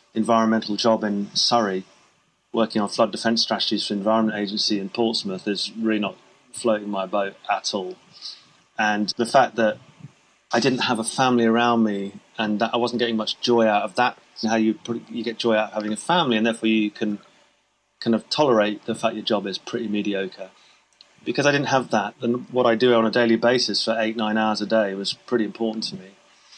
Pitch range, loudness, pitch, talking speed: 105-115 Hz, -22 LUFS, 110 Hz, 210 wpm